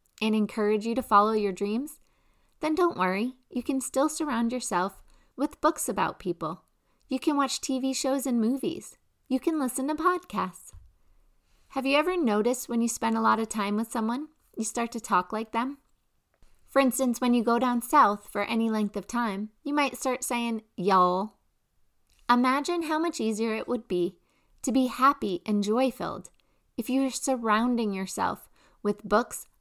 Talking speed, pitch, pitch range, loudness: 175 wpm, 240 Hz, 215-270 Hz, -27 LUFS